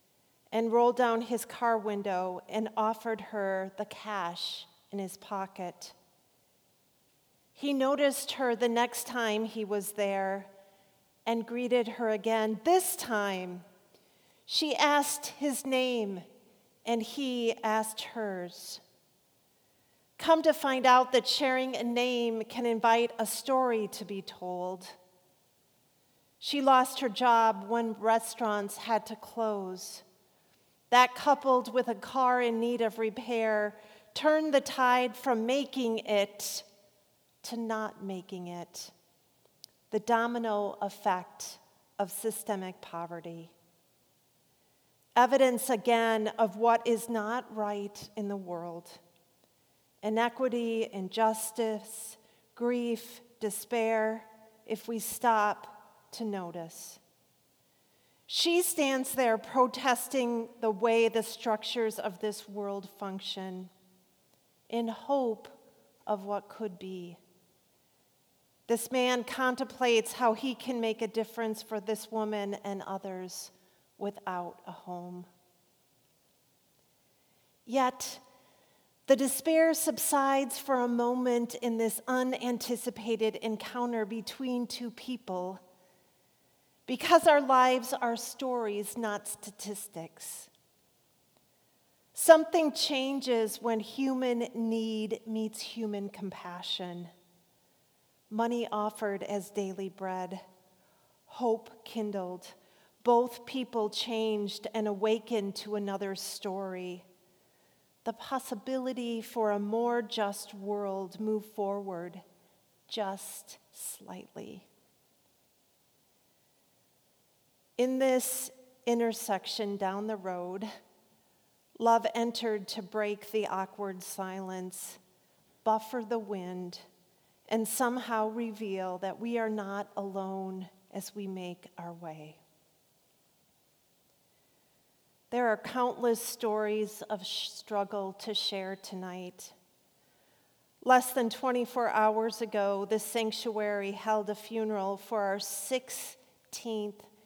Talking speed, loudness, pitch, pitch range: 100 wpm, -31 LUFS, 220 Hz, 200-240 Hz